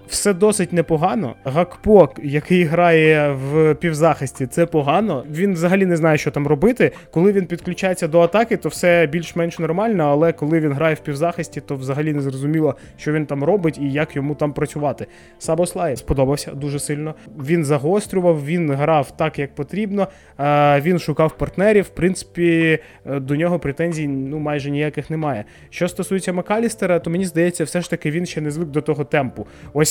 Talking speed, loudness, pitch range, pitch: 175 wpm, -19 LUFS, 145-175 Hz, 160 Hz